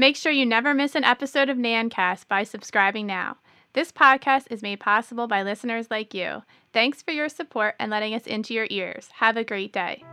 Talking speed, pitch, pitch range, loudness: 210 wpm, 225 Hz, 205-270 Hz, -23 LUFS